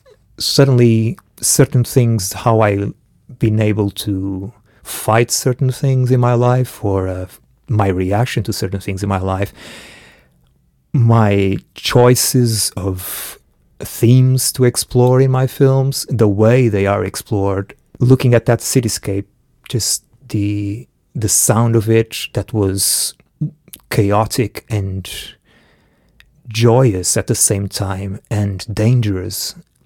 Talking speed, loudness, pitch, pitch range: 115 wpm, -15 LUFS, 110 Hz, 100-125 Hz